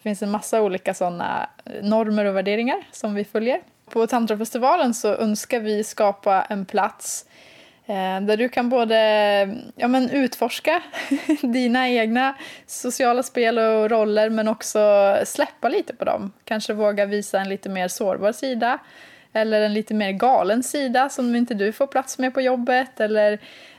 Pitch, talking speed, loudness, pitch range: 220 Hz, 155 wpm, -21 LUFS, 210-255 Hz